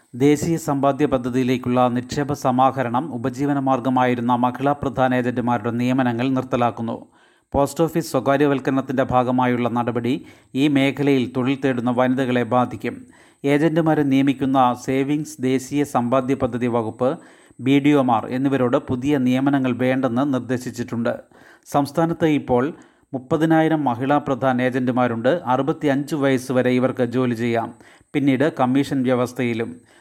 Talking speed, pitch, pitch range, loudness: 110 wpm, 130 Hz, 125-140 Hz, -20 LUFS